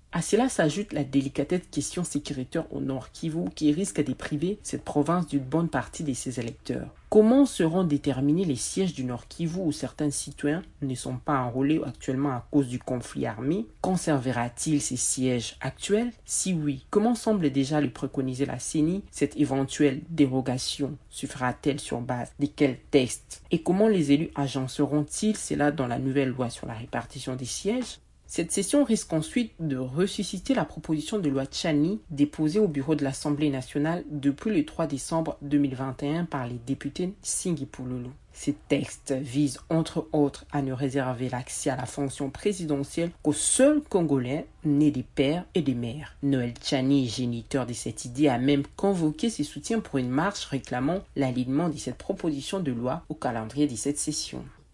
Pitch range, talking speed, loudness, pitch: 135-165 Hz, 170 wpm, -27 LUFS, 145 Hz